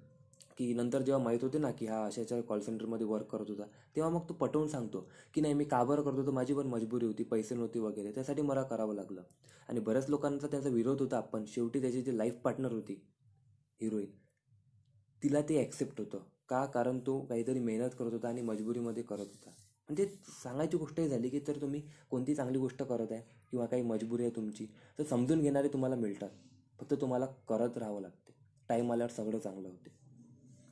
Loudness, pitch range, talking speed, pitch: -36 LUFS, 110-135 Hz, 190 wpm, 120 Hz